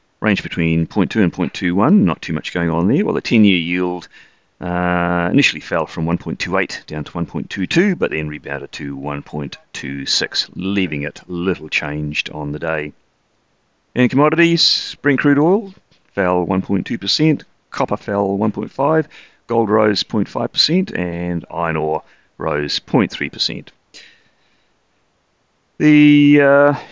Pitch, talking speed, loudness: 90 Hz, 125 wpm, -17 LUFS